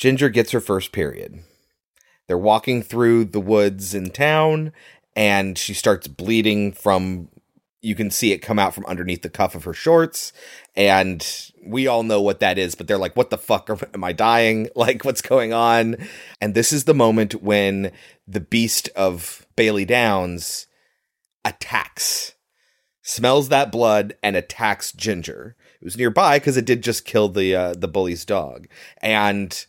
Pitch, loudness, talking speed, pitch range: 105 Hz, -19 LUFS, 165 wpm, 95-115 Hz